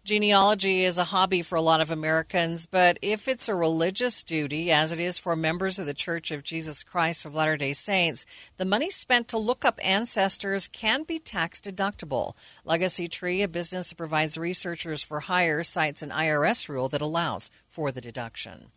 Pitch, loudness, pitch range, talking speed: 170 Hz, -24 LUFS, 160-195 Hz, 190 wpm